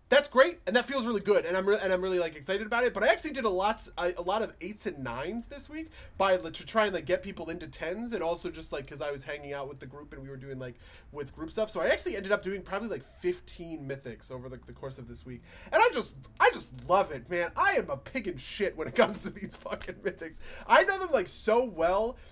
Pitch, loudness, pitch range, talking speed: 180 Hz, -30 LUFS, 145-220 Hz, 280 wpm